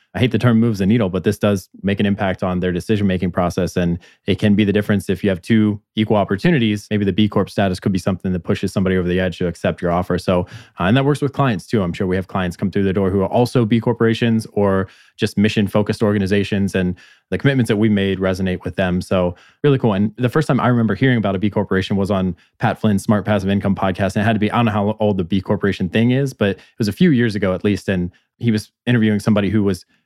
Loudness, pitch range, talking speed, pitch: -18 LUFS, 95-110 Hz, 275 wpm, 100 Hz